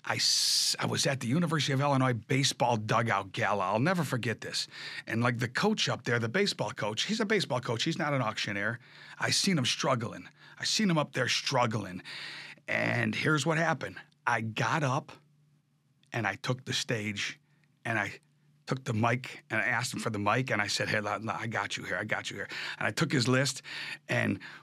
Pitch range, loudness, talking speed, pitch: 115-150 Hz, -30 LUFS, 205 wpm, 130 Hz